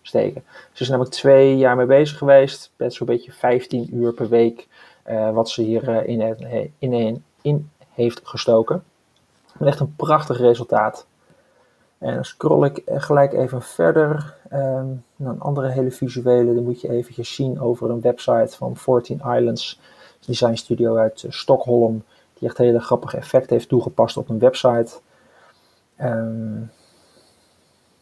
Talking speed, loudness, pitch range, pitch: 160 wpm, -19 LUFS, 115-135 Hz, 125 Hz